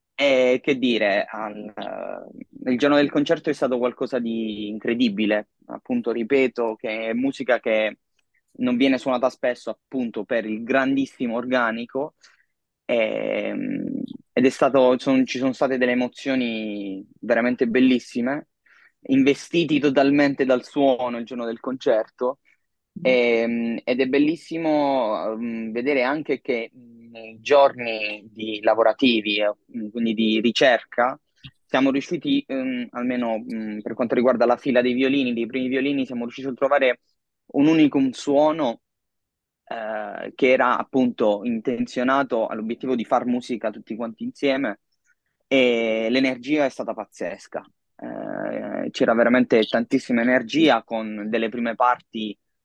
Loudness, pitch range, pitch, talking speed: -22 LUFS, 115-135 Hz, 125 Hz, 120 wpm